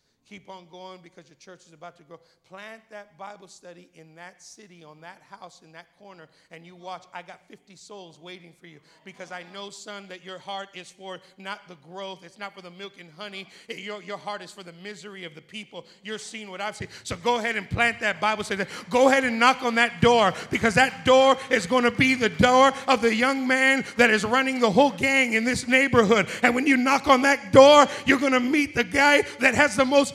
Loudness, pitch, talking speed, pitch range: -20 LUFS, 205 Hz, 240 wpm, 180-250 Hz